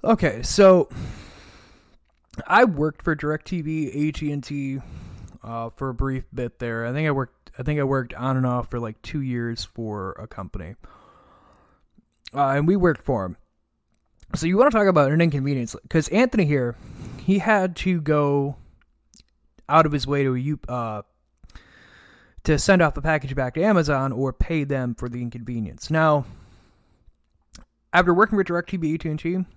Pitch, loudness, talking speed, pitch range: 140 Hz, -22 LUFS, 170 wpm, 120-160 Hz